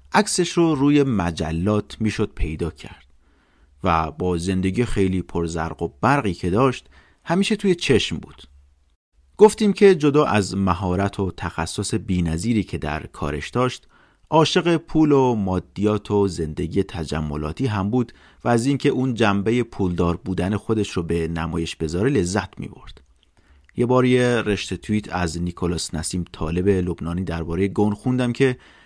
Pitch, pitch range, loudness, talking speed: 95 Hz, 80-125 Hz, -21 LUFS, 145 wpm